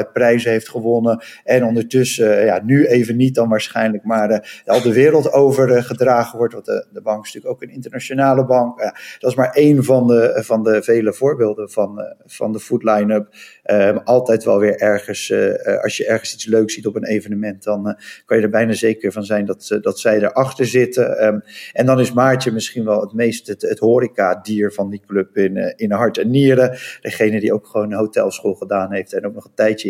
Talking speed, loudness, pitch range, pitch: 215 wpm, -16 LUFS, 105-125 Hz, 115 Hz